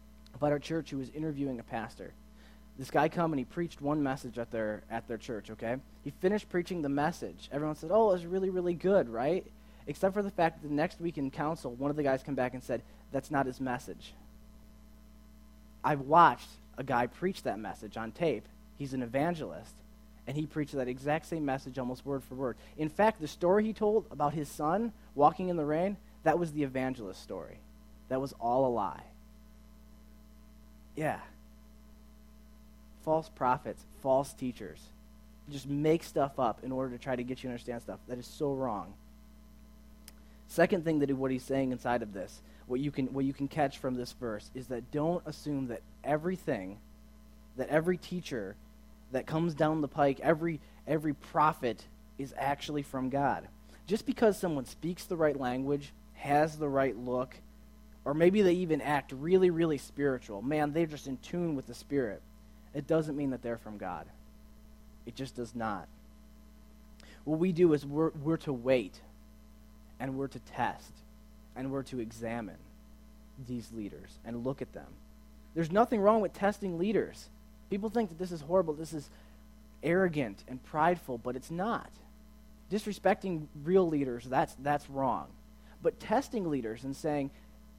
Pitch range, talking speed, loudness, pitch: 105-155 Hz, 175 wpm, -33 LUFS, 135 Hz